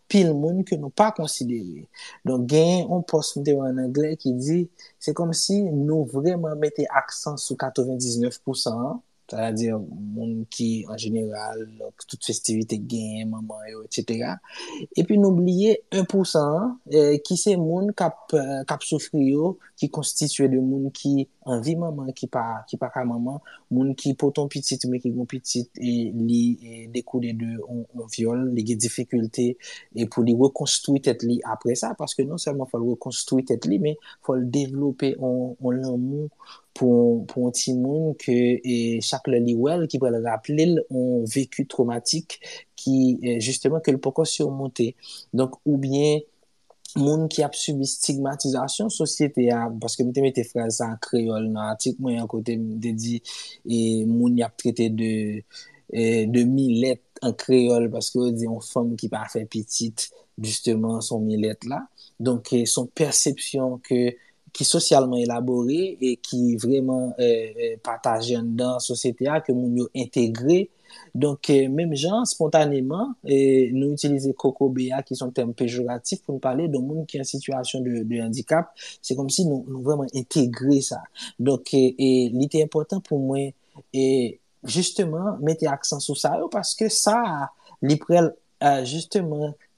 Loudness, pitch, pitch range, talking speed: -23 LUFS, 130 Hz, 120-150 Hz, 170 wpm